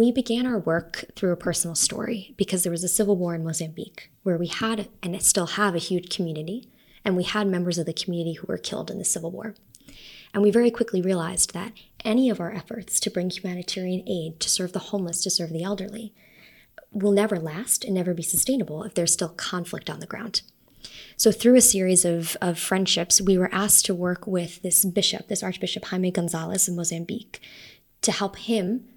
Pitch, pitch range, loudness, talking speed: 190 Hz, 175-215 Hz, -23 LUFS, 205 wpm